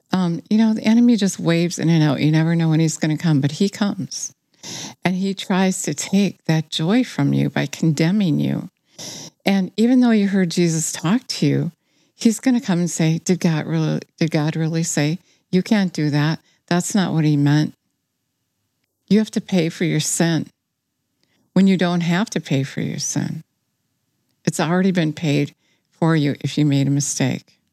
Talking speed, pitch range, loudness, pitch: 195 wpm, 150-185 Hz, -19 LUFS, 165 Hz